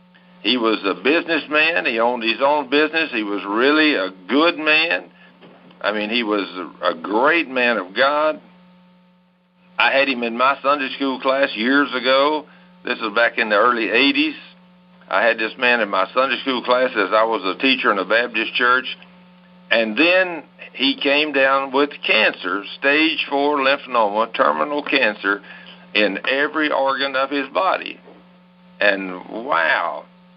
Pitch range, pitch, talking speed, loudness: 120-180 Hz, 140 Hz, 155 wpm, -18 LUFS